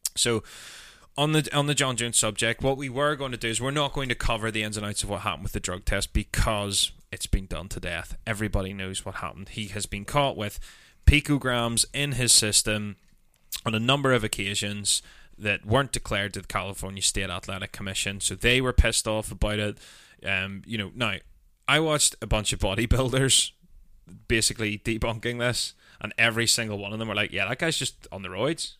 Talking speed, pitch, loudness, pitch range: 205 wpm, 110 Hz, -25 LUFS, 100-120 Hz